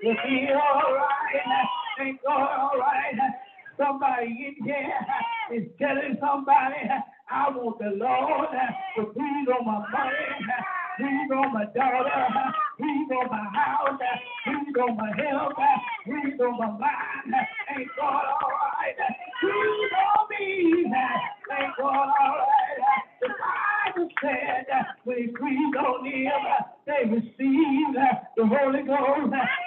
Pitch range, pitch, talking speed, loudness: 255-300 Hz, 275 Hz, 130 wpm, -25 LUFS